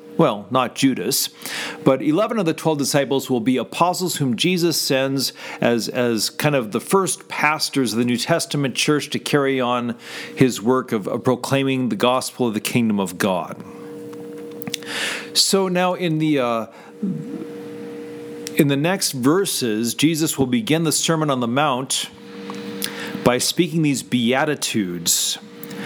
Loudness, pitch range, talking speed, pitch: -20 LUFS, 125-160 Hz, 145 wpm, 140 Hz